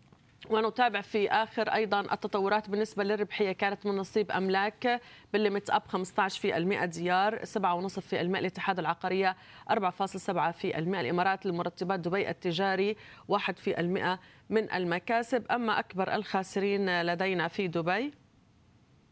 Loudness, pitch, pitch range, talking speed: -30 LUFS, 195 Hz, 185-210 Hz, 125 wpm